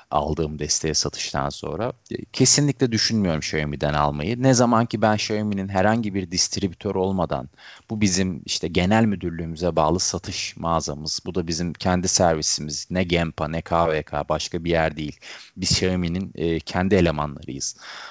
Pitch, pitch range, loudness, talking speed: 90 Hz, 80-100 Hz, -22 LUFS, 140 wpm